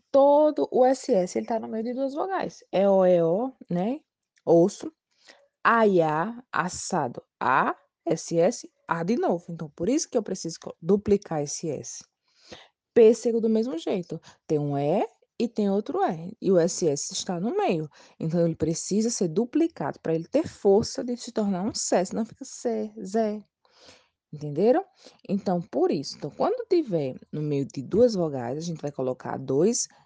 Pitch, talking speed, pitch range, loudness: 205 Hz, 170 wpm, 165-250 Hz, -26 LUFS